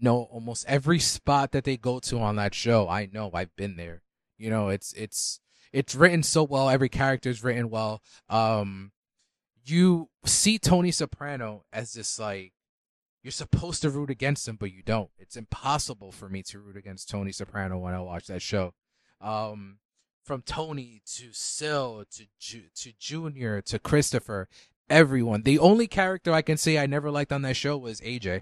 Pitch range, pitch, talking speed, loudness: 100-145 Hz, 120 Hz, 180 wpm, -26 LUFS